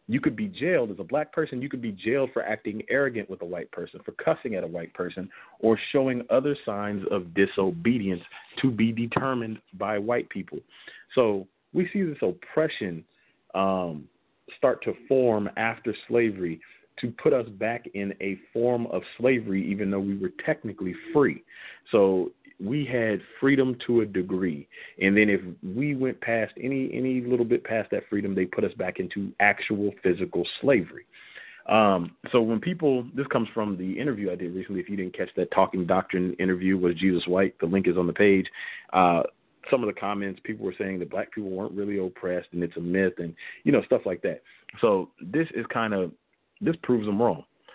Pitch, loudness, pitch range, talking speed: 105 Hz, -26 LUFS, 95-125 Hz, 190 wpm